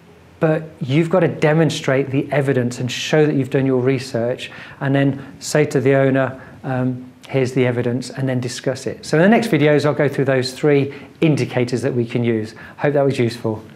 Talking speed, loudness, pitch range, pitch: 205 wpm, -18 LUFS, 125-150 Hz, 135 Hz